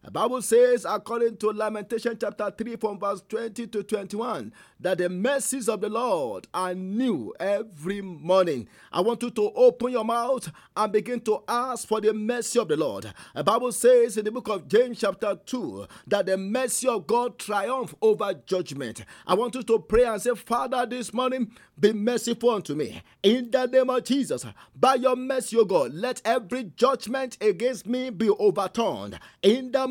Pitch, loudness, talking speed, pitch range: 230 Hz, -25 LUFS, 185 wpm, 205-250 Hz